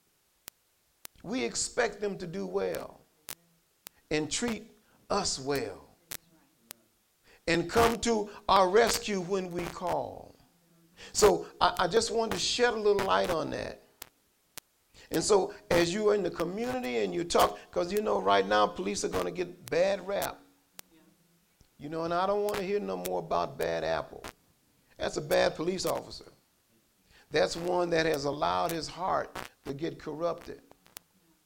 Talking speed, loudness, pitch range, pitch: 155 wpm, -30 LUFS, 165-210 Hz, 180 Hz